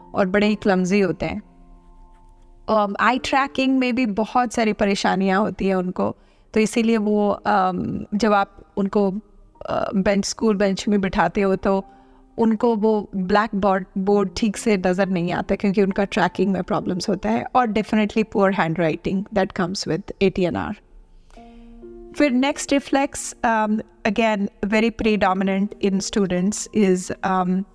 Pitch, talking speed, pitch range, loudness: 205 Hz, 150 wpm, 190-220 Hz, -21 LUFS